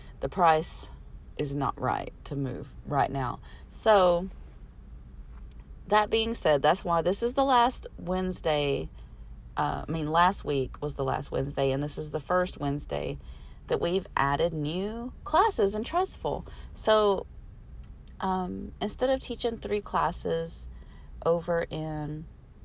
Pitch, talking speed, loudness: 155 Hz, 135 wpm, -28 LUFS